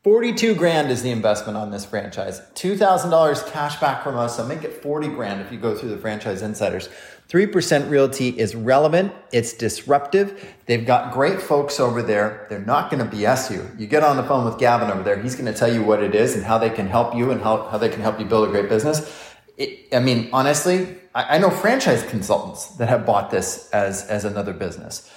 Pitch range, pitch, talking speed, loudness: 110-150 Hz, 125 Hz, 220 wpm, -20 LUFS